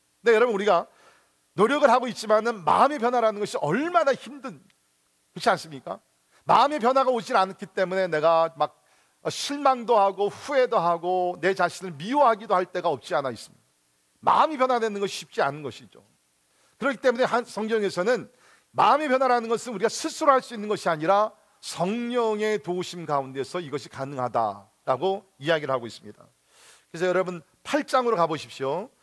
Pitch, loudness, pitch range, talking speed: 200 Hz, -24 LUFS, 170-245 Hz, 370 characters per minute